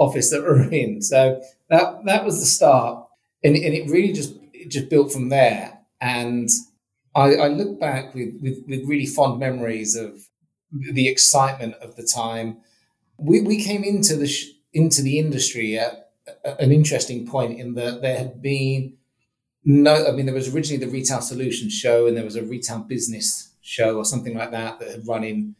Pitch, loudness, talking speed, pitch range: 130 Hz, -20 LUFS, 190 wpm, 115-145 Hz